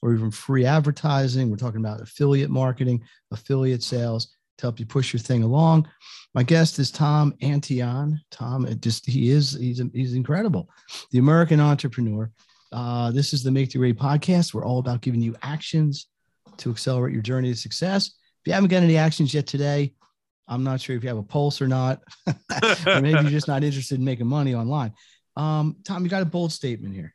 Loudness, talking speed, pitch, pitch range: -23 LUFS, 200 wpm, 135 Hz, 125-150 Hz